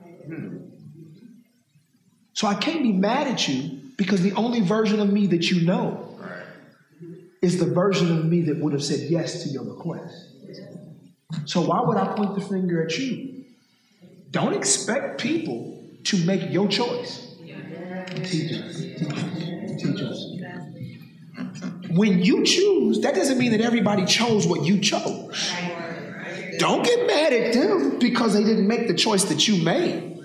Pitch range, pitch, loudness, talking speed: 170-210 Hz, 185 Hz, -22 LUFS, 140 wpm